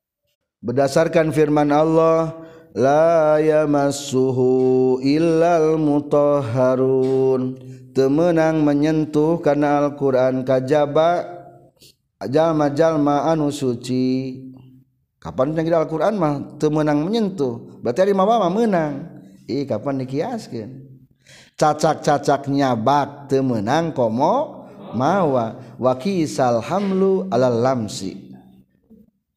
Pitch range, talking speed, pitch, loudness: 130-160 Hz, 100 wpm, 145 Hz, -19 LUFS